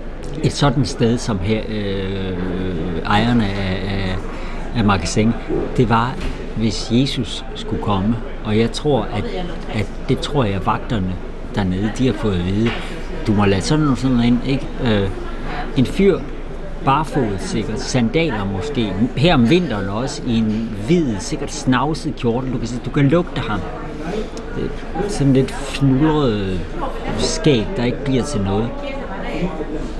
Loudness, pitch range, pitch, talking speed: -19 LUFS, 100-130 Hz, 115 Hz, 150 wpm